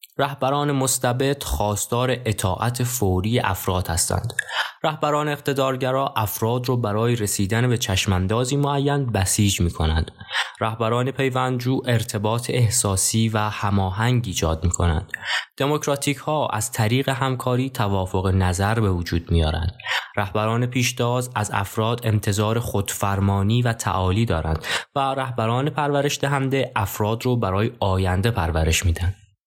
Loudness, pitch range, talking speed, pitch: -22 LUFS, 100-130 Hz, 120 wpm, 110 Hz